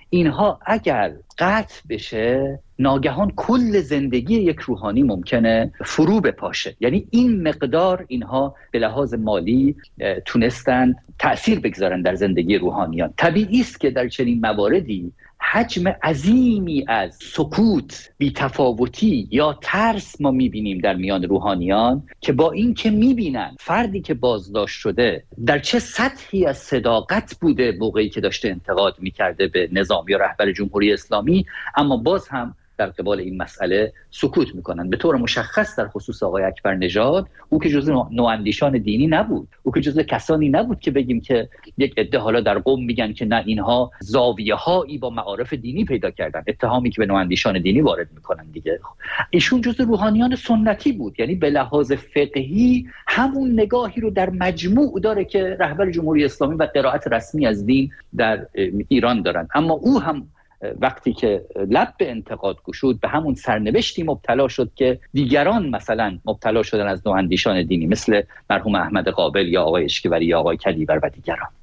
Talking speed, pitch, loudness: 155 wpm, 140 Hz, -20 LUFS